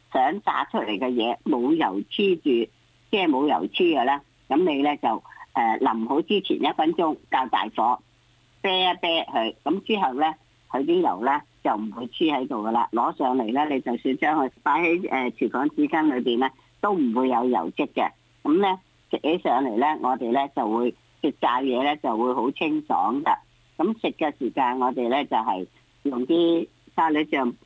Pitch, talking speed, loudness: 170 Hz, 250 characters per minute, -24 LUFS